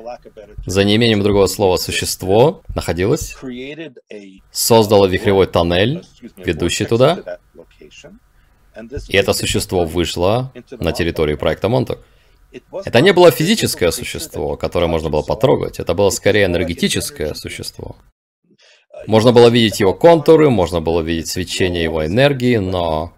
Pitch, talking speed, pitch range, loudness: 105 Hz, 115 wpm, 85-125 Hz, -15 LUFS